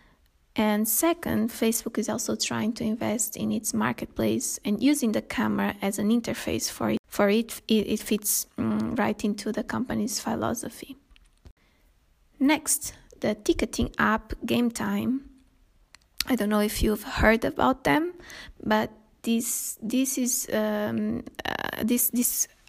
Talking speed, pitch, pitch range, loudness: 140 wpm, 225 Hz, 215-255 Hz, -26 LUFS